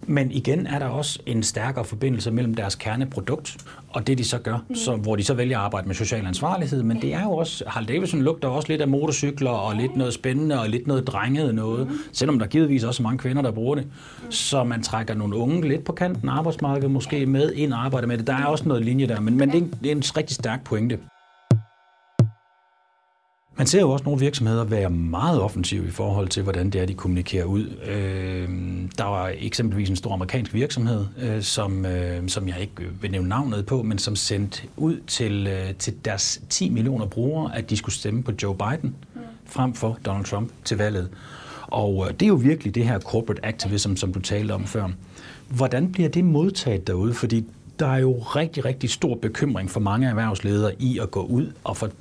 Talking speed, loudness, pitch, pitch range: 210 wpm, -24 LUFS, 120 Hz, 105-140 Hz